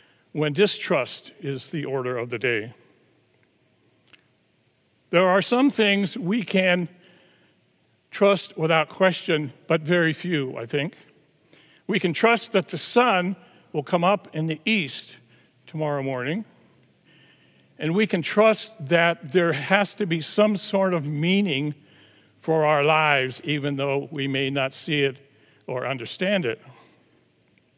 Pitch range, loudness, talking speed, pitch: 140-190 Hz, -23 LUFS, 135 wpm, 160 Hz